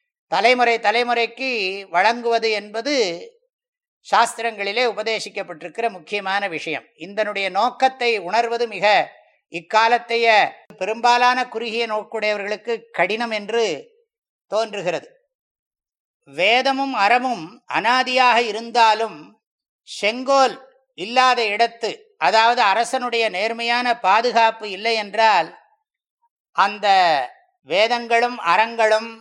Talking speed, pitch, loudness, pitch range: 70 wpm, 230 Hz, -19 LUFS, 210-250 Hz